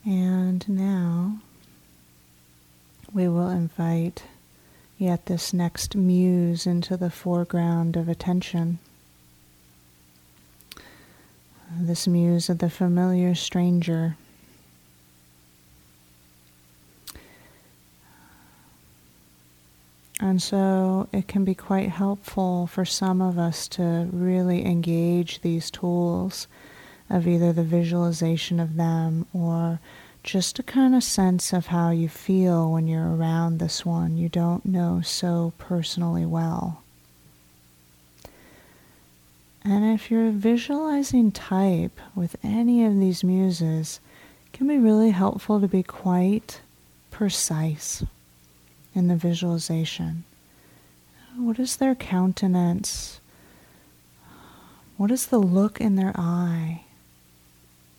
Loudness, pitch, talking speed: -24 LUFS, 170 Hz, 100 wpm